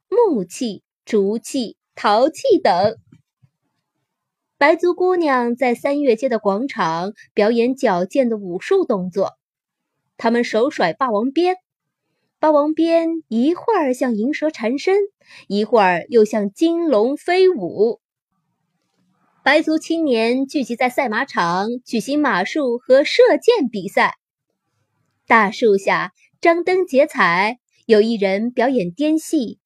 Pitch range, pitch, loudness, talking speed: 225-325 Hz, 265 Hz, -18 LUFS, 175 characters per minute